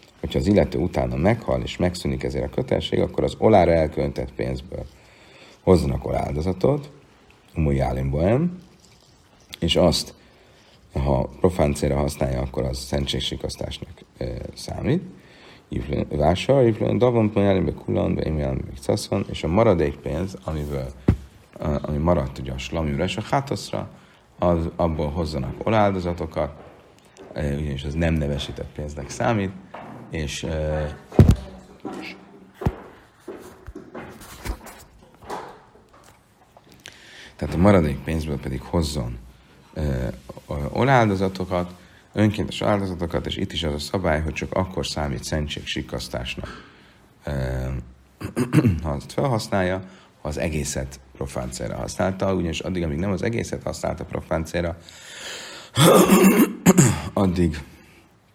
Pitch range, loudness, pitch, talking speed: 70-95 Hz, -23 LUFS, 80 Hz, 100 wpm